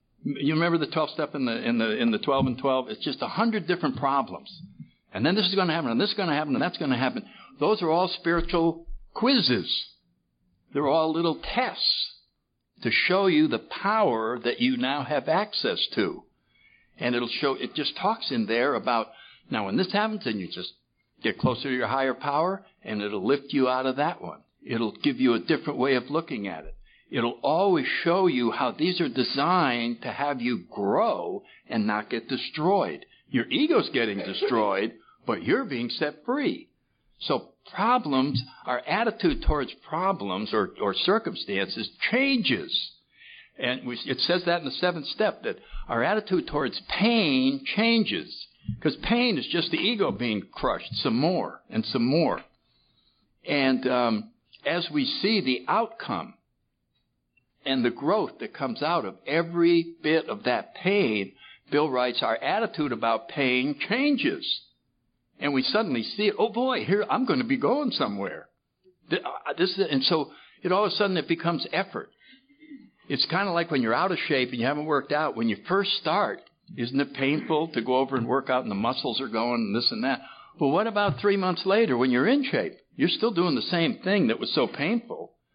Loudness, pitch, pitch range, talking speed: -26 LUFS, 165 Hz, 130-215 Hz, 190 wpm